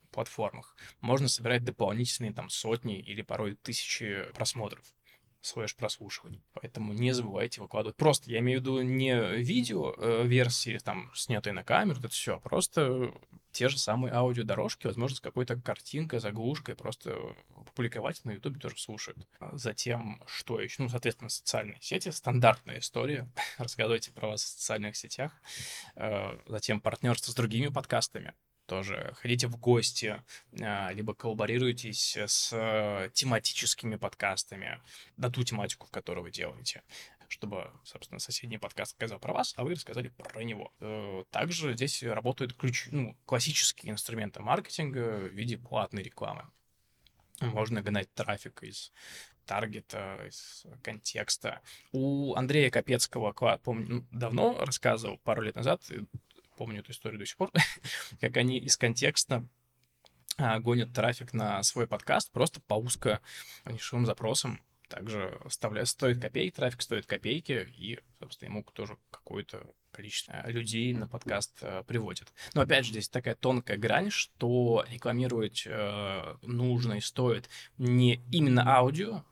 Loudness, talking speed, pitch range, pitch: -32 LUFS, 135 wpm, 110-125 Hz, 120 Hz